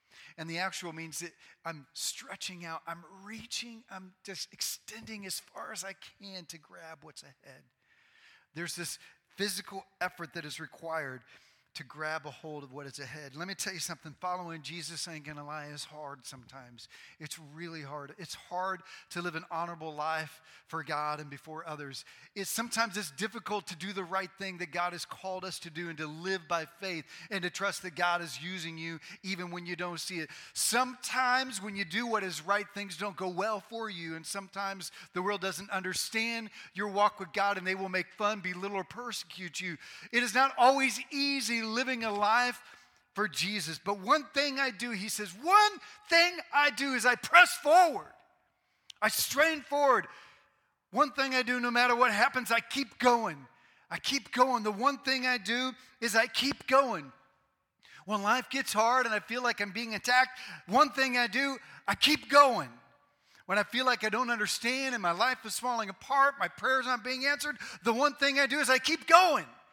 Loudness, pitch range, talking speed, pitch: -30 LUFS, 170-250 Hz, 195 wpm, 200 Hz